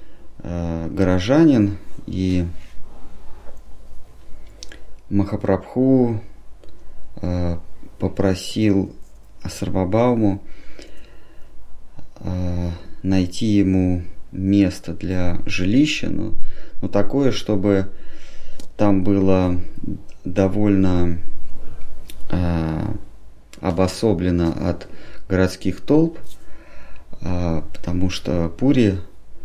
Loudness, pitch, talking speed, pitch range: -21 LUFS, 95 Hz, 50 wpm, 85-100 Hz